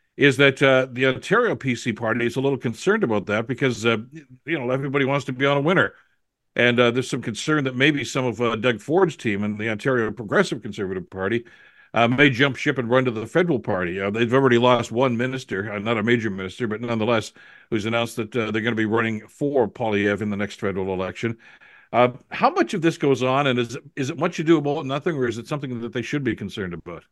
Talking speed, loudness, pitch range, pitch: 240 wpm, -22 LUFS, 115-140 Hz, 125 Hz